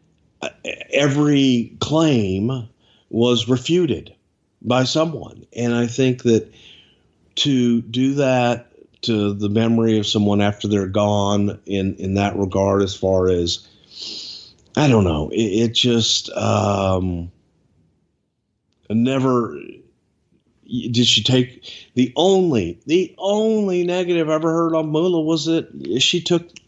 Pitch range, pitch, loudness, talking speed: 105-145 Hz, 120 Hz, -19 LUFS, 120 wpm